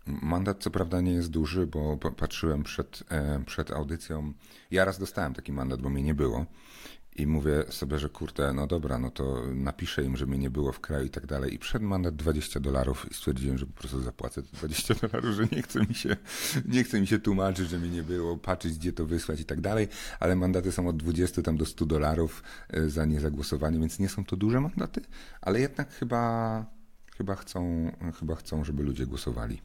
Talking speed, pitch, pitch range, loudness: 205 wpm, 80 Hz, 70-95 Hz, -31 LUFS